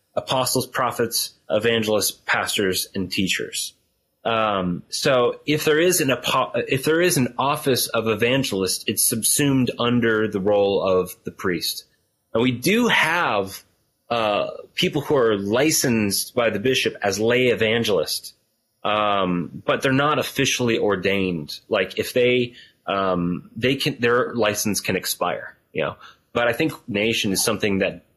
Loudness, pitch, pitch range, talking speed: -21 LUFS, 115 Hz, 100-130 Hz, 145 wpm